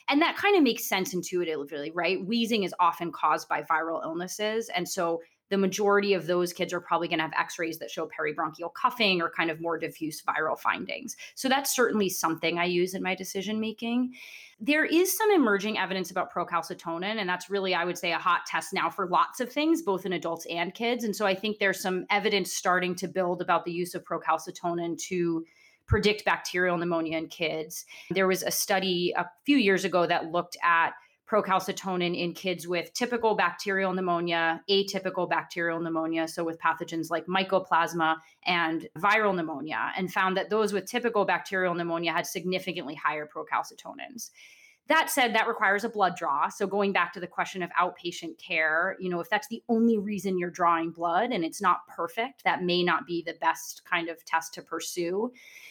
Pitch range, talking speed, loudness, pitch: 170-200 Hz, 195 wpm, -28 LUFS, 180 Hz